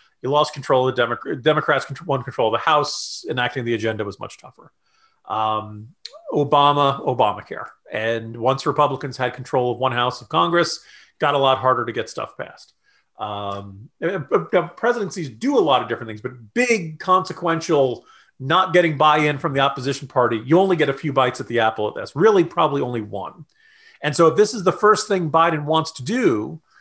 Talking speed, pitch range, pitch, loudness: 190 wpm, 125-170 Hz, 145 Hz, -20 LUFS